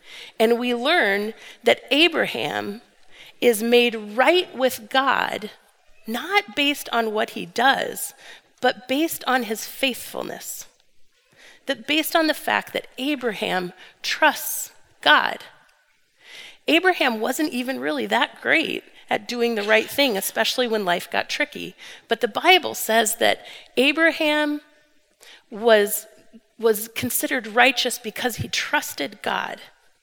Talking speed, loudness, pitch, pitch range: 120 wpm, -21 LUFS, 255 Hz, 230-305 Hz